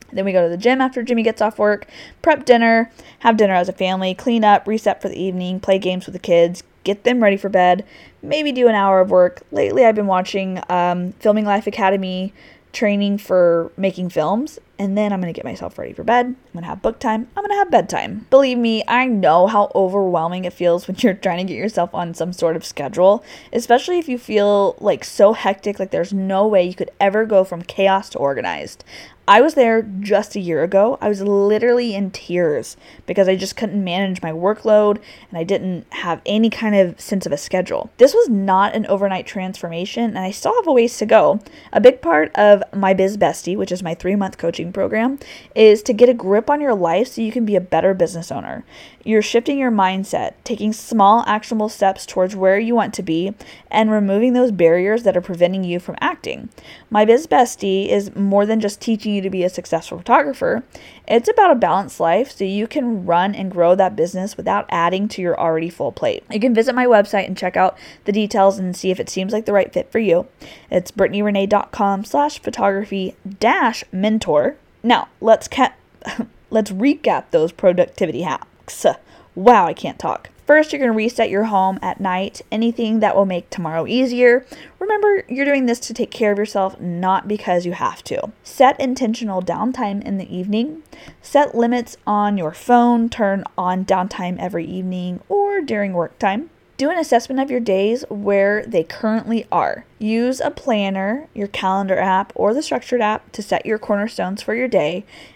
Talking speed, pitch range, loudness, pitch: 200 wpm, 185-235 Hz, -17 LUFS, 205 Hz